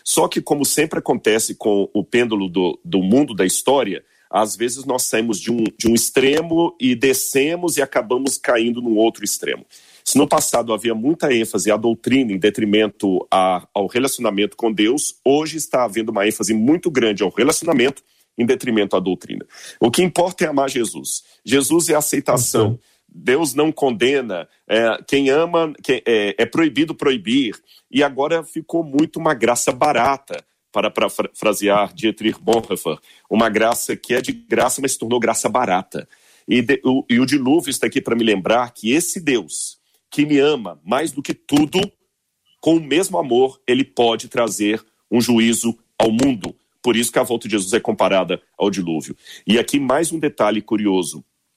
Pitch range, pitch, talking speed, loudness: 110-155 Hz, 125 Hz, 175 wpm, -18 LUFS